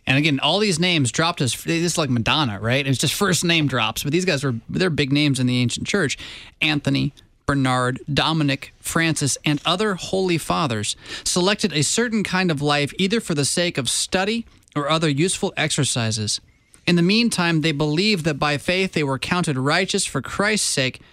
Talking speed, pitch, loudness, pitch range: 190 wpm, 155 Hz, -20 LUFS, 135-180 Hz